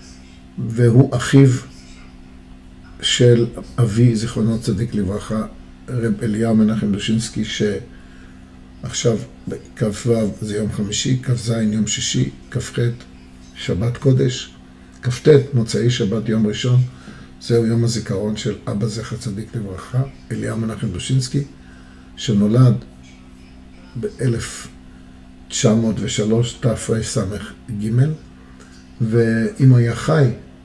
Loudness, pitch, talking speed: -19 LUFS, 110 Hz, 90 wpm